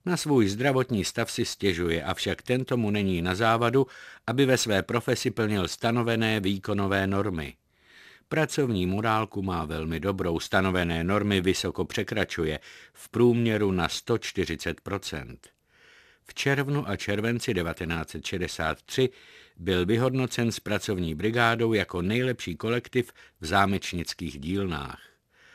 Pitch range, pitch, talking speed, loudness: 90-115 Hz, 100 Hz, 115 wpm, -27 LUFS